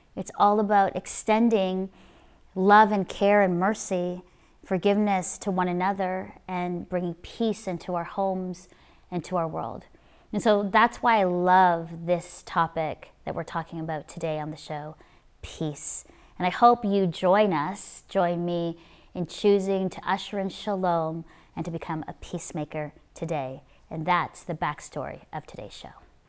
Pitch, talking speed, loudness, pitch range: 180 Hz, 155 wpm, -26 LUFS, 165-195 Hz